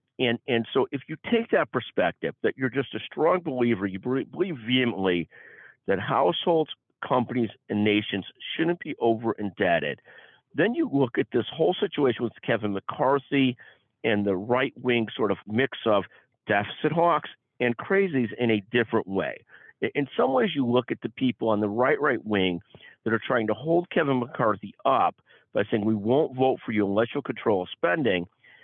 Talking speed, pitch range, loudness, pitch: 175 wpm, 110-135 Hz, -26 LUFS, 120 Hz